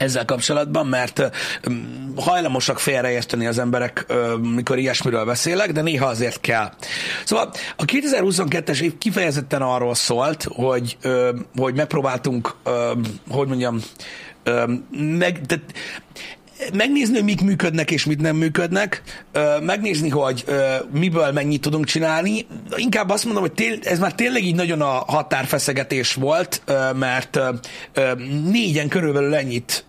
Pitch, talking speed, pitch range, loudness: 145 Hz, 115 wpm, 125-175 Hz, -20 LUFS